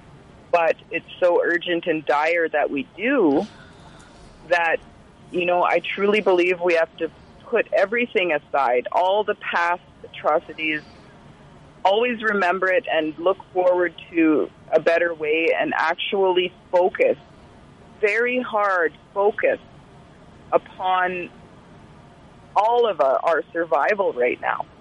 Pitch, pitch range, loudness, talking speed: 180 Hz, 165-210 Hz, -21 LUFS, 120 wpm